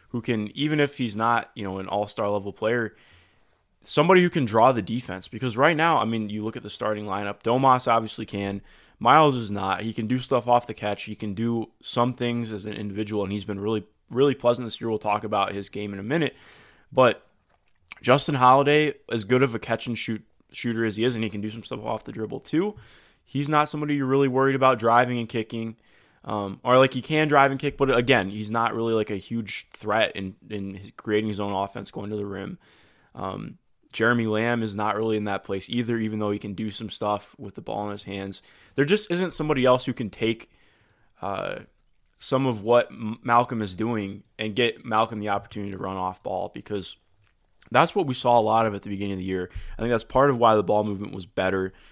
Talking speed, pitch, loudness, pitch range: 230 wpm, 110 Hz, -24 LUFS, 100-125 Hz